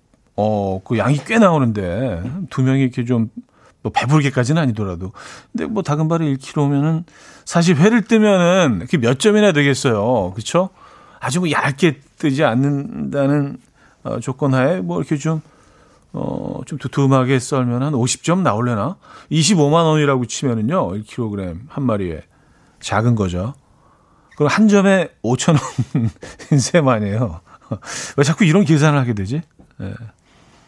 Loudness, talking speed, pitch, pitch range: -17 LUFS, 270 characters per minute, 140 Hz, 120-160 Hz